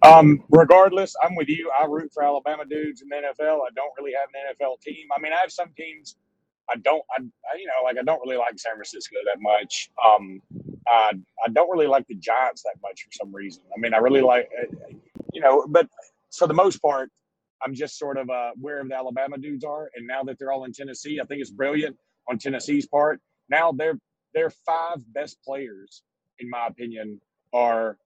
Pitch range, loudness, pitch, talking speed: 125-155 Hz, -22 LUFS, 140 Hz, 215 wpm